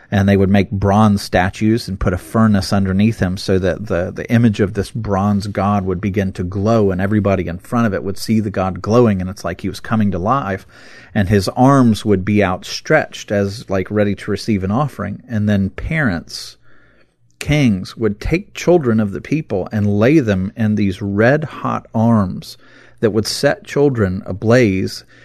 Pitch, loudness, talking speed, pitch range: 105 Hz, -16 LUFS, 190 wpm, 95-115 Hz